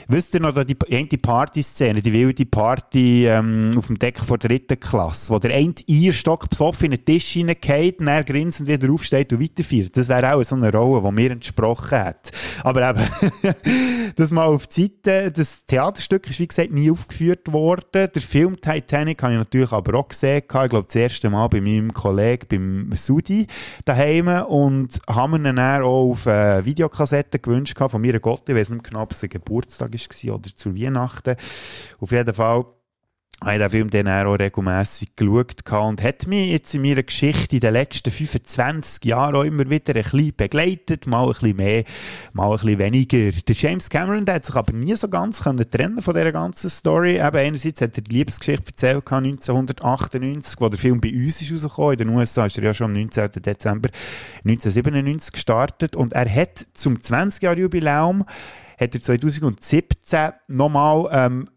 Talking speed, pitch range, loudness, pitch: 180 wpm, 115-150 Hz, -19 LUFS, 130 Hz